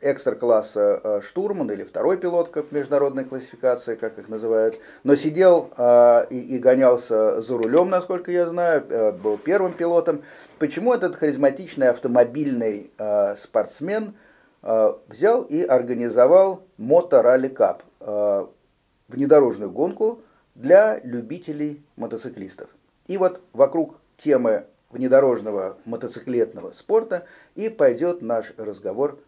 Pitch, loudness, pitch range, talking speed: 150 Hz, -21 LUFS, 125-185 Hz, 115 wpm